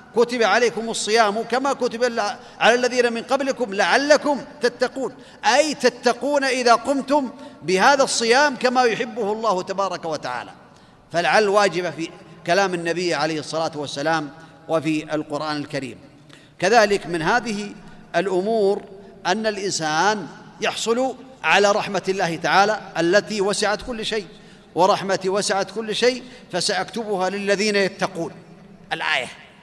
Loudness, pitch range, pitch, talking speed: -21 LUFS, 180-240 Hz, 205 Hz, 115 wpm